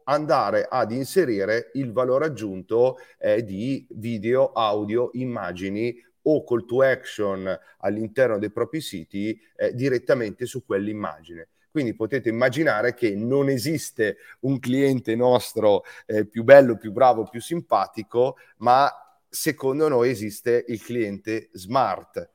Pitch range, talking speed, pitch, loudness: 110-135 Hz, 125 wpm, 120 Hz, -23 LUFS